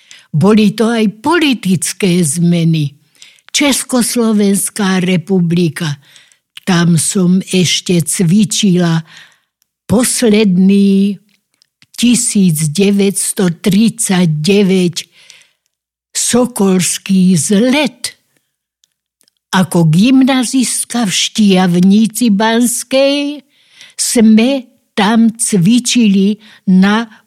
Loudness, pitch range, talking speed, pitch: -11 LUFS, 185-235 Hz, 55 wpm, 200 Hz